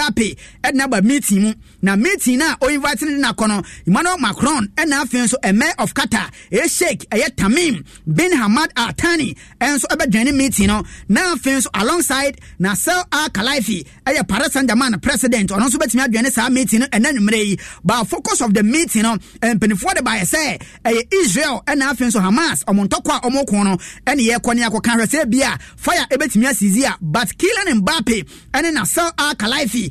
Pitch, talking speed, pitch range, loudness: 245 Hz, 205 wpm, 215-290 Hz, -16 LUFS